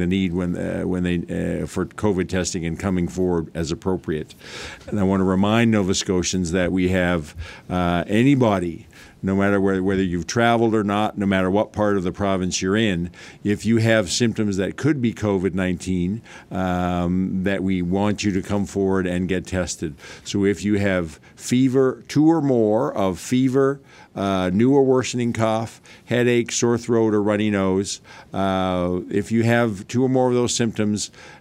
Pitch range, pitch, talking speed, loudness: 90-110 Hz, 100 Hz, 180 wpm, -21 LUFS